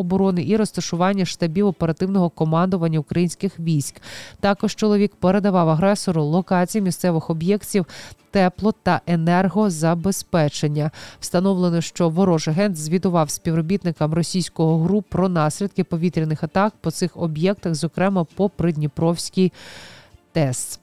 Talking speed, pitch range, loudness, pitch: 105 wpm, 165-195 Hz, -20 LUFS, 175 Hz